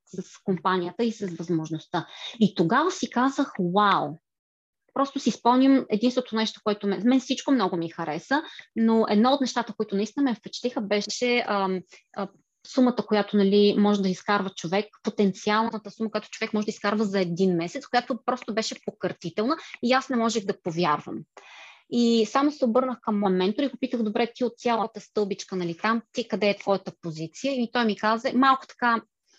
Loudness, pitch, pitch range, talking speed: -25 LUFS, 215 Hz, 195-245 Hz, 180 wpm